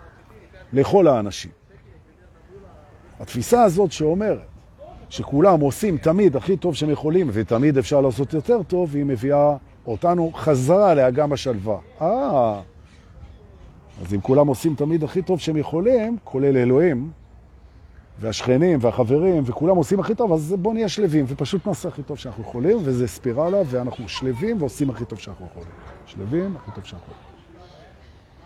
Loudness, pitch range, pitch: -20 LUFS, 110-175 Hz, 140 Hz